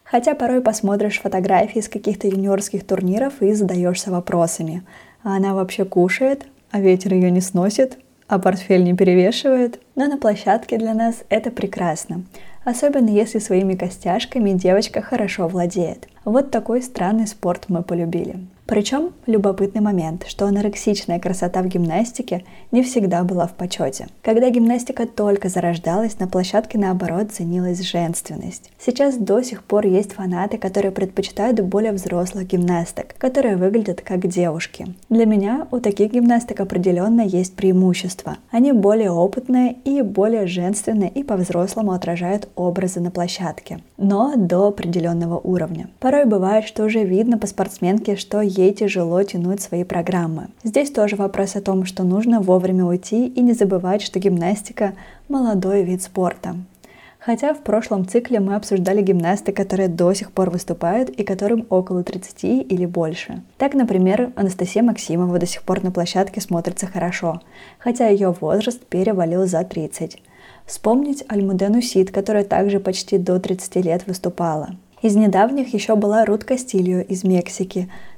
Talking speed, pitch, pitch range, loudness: 145 wpm, 195 Hz, 180-220 Hz, -19 LUFS